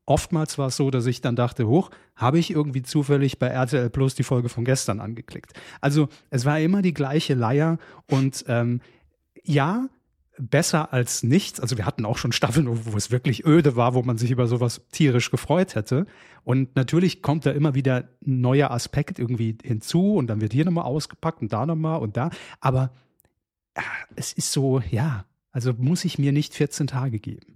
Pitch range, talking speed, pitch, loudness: 125-150 Hz, 195 wpm, 135 Hz, -23 LUFS